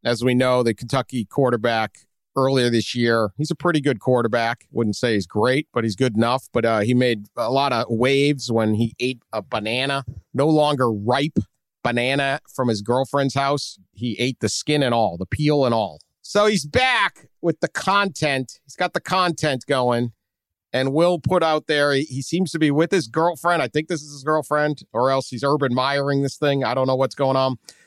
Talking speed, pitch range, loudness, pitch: 205 wpm, 120-150 Hz, -21 LUFS, 130 Hz